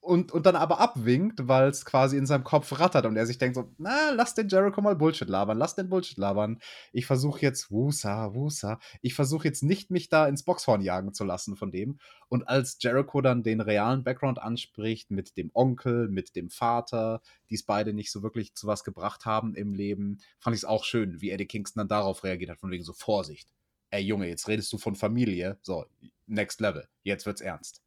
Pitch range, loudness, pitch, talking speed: 105-140 Hz, -28 LUFS, 115 Hz, 215 wpm